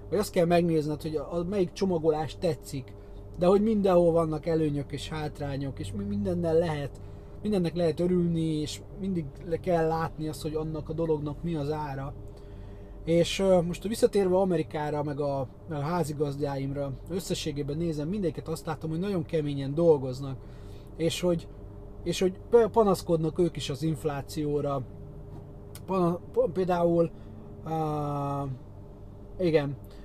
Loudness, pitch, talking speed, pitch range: -28 LUFS, 155 Hz, 135 wpm, 135-170 Hz